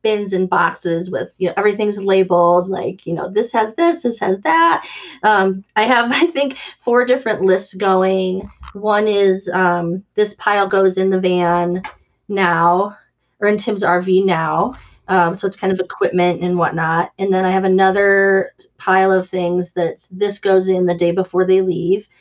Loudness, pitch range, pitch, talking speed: -16 LUFS, 180-205 Hz, 190 Hz, 180 wpm